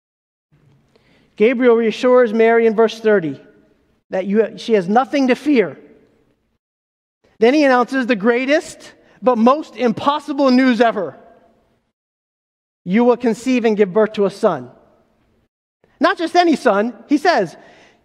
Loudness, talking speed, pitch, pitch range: -16 LUFS, 125 wpm, 240 Hz, 220-265 Hz